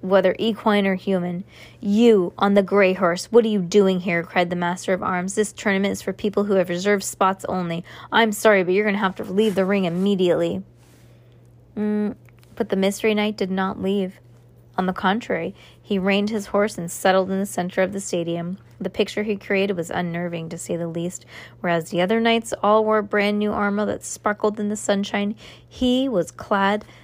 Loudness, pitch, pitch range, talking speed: -21 LUFS, 195 Hz, 180-210 Hz, 200 wpm